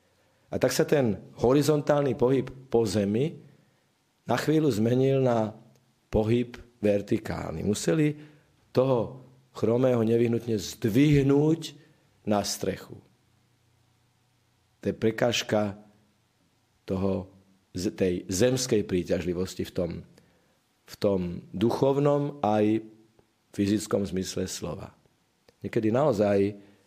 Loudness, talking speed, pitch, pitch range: -27 LUFS, 85 wpm, 115 Hz, 105-125 Hz